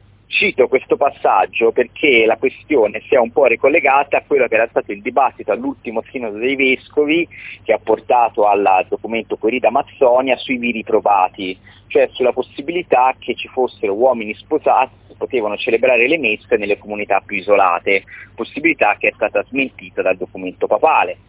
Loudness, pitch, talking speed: -16 LUFS, 135 Hz, 160 wpm